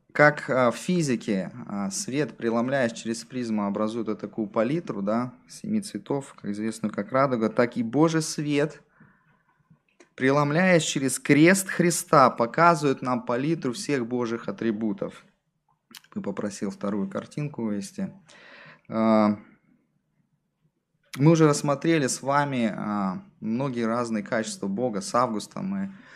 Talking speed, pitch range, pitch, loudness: 110 wpm, 110-160 Hz, 130 Hz, -25 LUFS